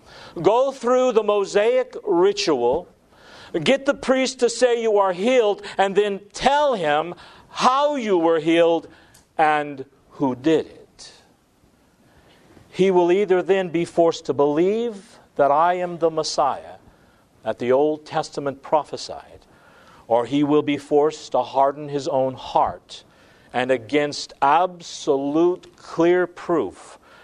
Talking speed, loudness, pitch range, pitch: 130 wpm, -20 LUFS, 145-215 Hz, 170 Hz